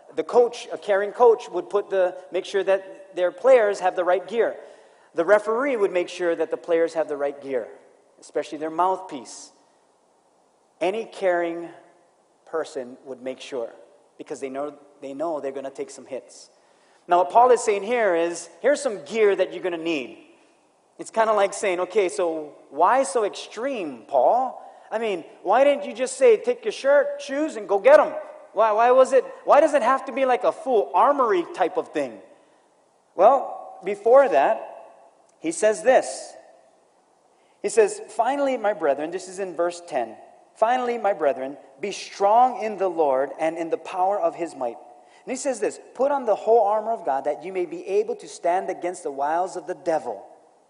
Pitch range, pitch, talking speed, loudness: 170-270 Hz, 200 Hz, 190 wpm, -22 LUFS